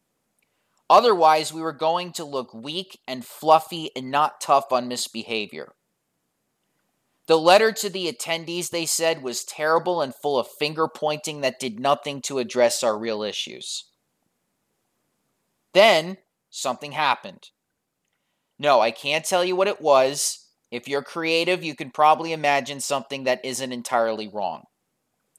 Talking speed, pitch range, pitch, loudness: 140 wpm, 130-160 Hz, 145 Hz, -22 LUFS